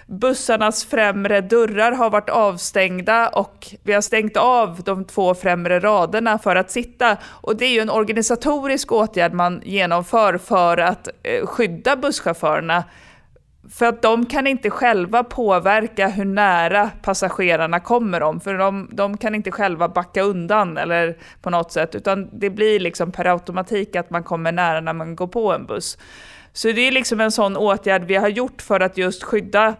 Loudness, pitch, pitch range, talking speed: -19 LUFS, 205 Hz, 185-225 Hz, 170 wpm